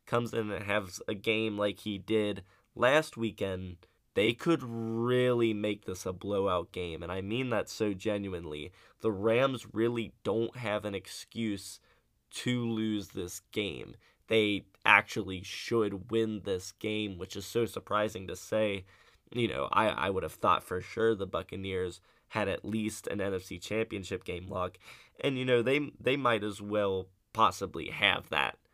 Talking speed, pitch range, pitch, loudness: 165 wpm, 95-115 Hz, 105 Hz, -32 LUFS